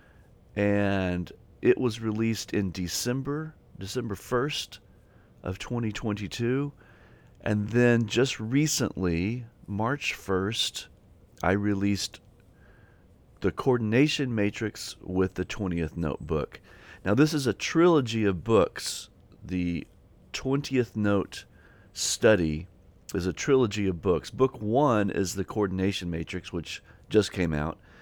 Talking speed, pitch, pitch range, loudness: 110 wpm, 105 Hz, 95-120 Hz, -28 LUFS